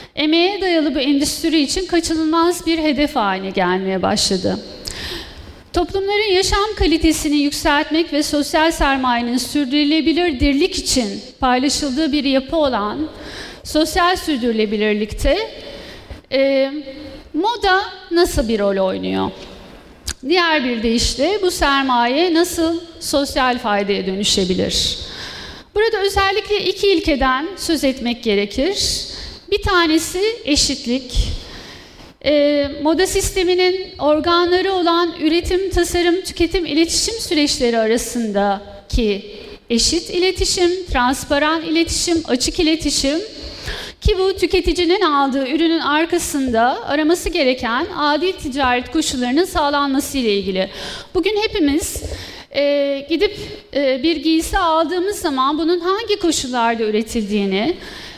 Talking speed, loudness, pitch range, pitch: 100 wpm, -17 LUFS, 260-350 Hz, 305 Hz